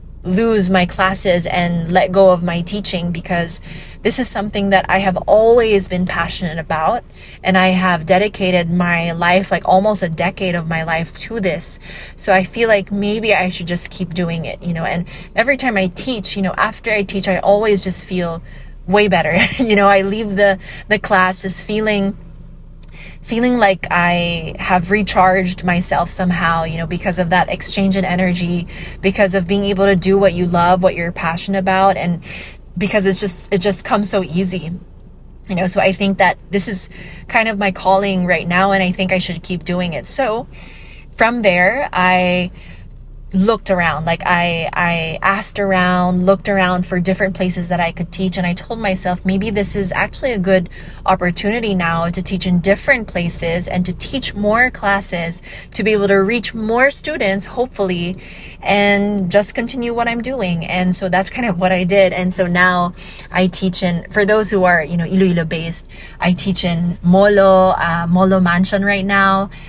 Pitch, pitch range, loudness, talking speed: 185 Hz, 175-200 Hz, -15 LUFS, 190 wpm